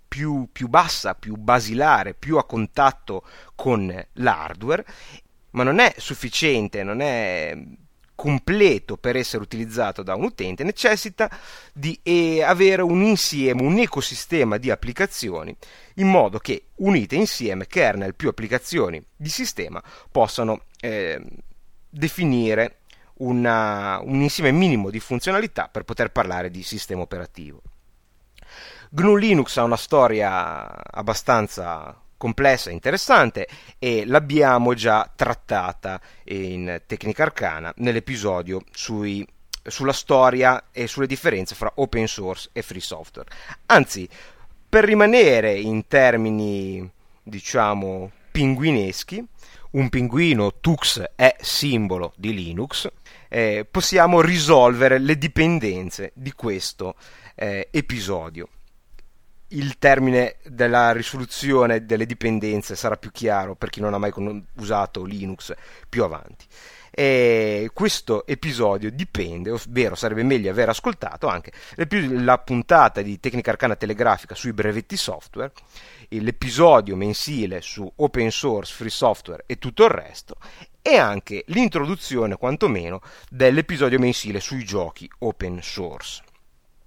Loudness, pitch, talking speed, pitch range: -21 LUFS, 120 Hz, 115 wpm, 105-140 Hz